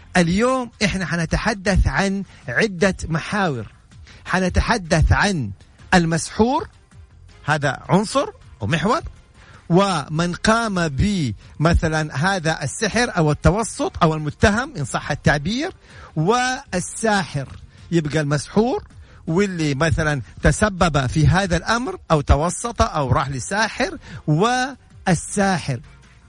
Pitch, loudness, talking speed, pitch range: 170 Hz, -20 LUFS, 90 wpm, 150-205 Hz